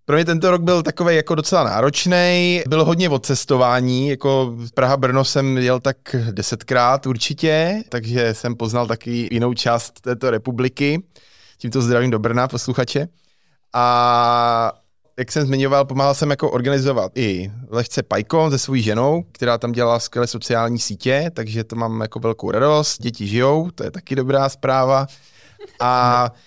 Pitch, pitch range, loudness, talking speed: 130 Hz, 120-145 Hz, -18 LUFS, 150 wpm